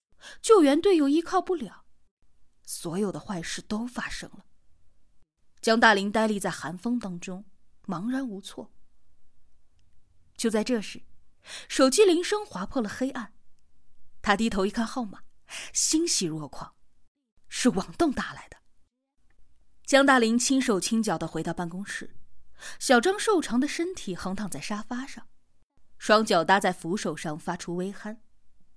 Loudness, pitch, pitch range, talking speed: -26 LUFS, 215 Hz, 175-260 Hz, 205 characters per minute